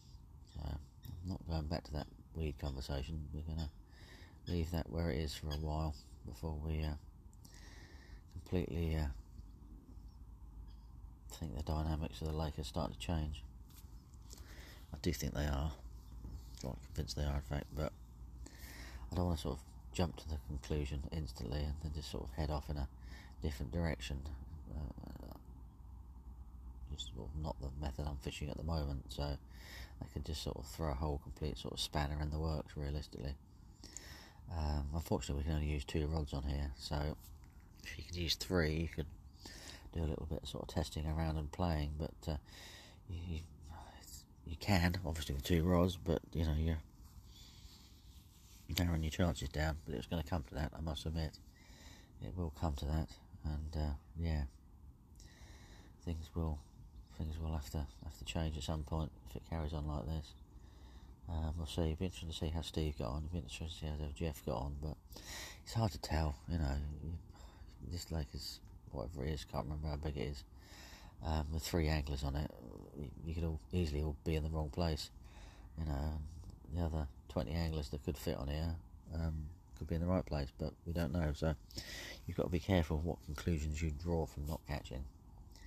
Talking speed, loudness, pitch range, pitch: 190 wpm, -42 LUFS, 75-85 Hz, 80 Hz